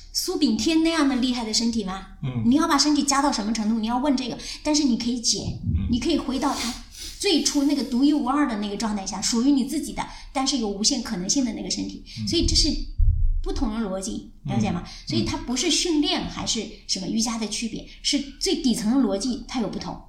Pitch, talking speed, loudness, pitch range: 255 Hz, 335 characters per minute, -24 LUFS, 225-290 Hz